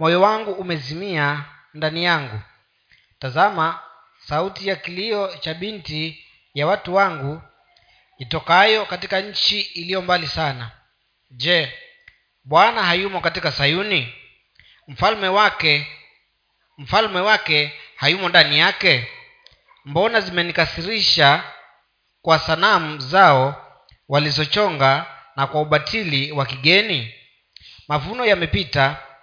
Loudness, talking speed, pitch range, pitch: -18 LUFS, 90 wpm, 145-195 Hz, 165 Hz